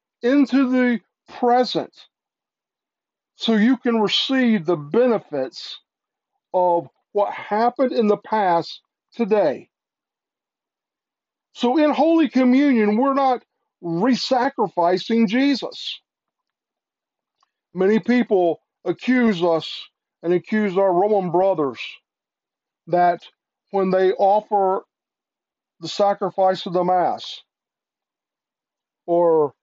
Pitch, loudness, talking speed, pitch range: 205 Hz, -20 LUFS, 90 wpm, 180-245 Hz